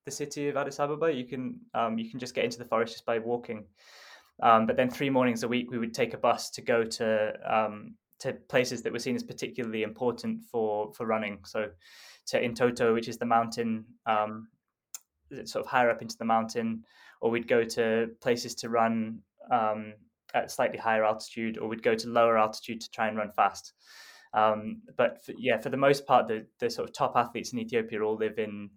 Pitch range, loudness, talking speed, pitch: 110-125 Hz, -29 LUFS, 215 wpm, 115 Hz